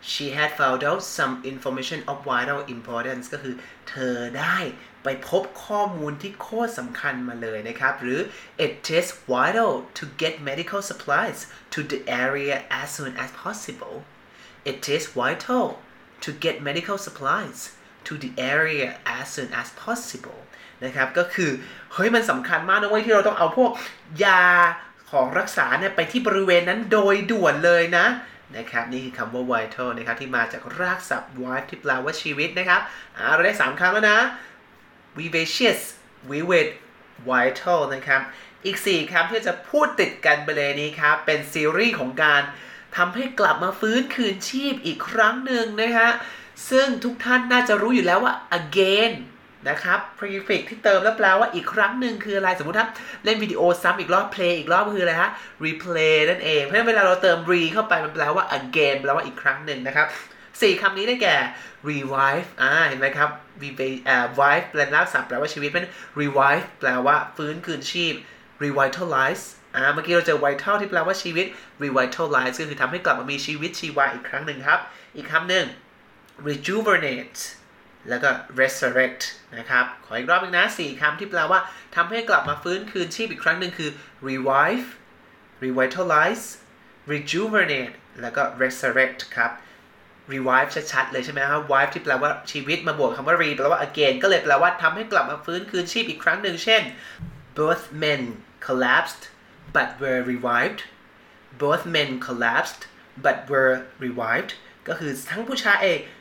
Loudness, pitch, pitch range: -22 LUFS, 160 Hz, 135-195 Hz